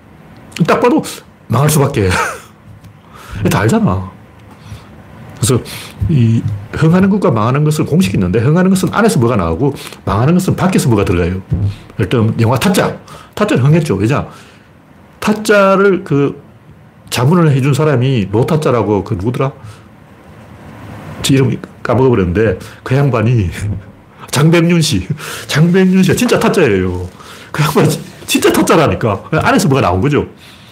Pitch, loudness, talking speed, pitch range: 125 Hz, -13 LUFS, 280 characters per minute, 105-160 Hz